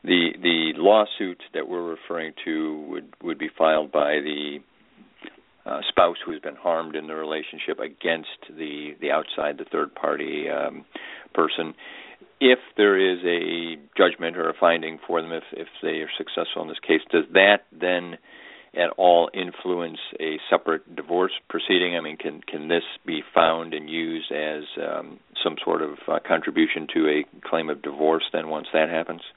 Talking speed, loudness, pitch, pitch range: 170 wpm, -24 LUFS, 80 Hz, 75-85 Hz